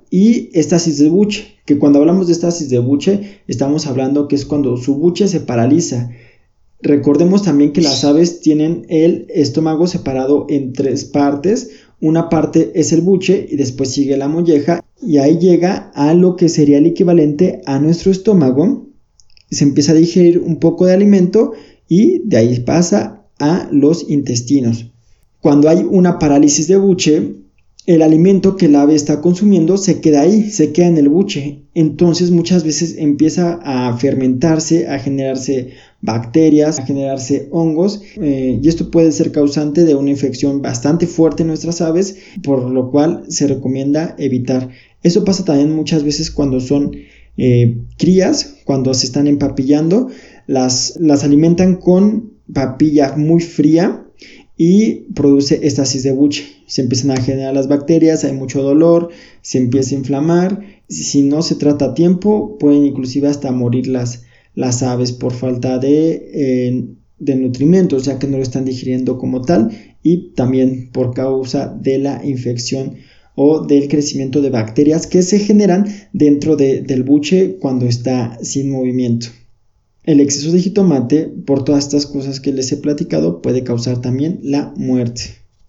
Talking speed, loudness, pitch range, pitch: 160 wpm, -13 LUFS, 135-170 Hz, 145 Hz